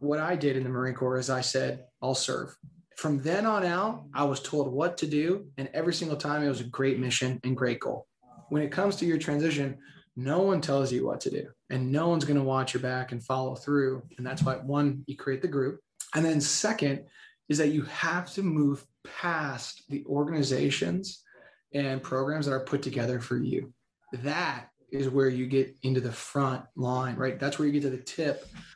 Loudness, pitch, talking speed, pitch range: -29 LUFS, 140 Hz, 215 wpm, 130-150 Hz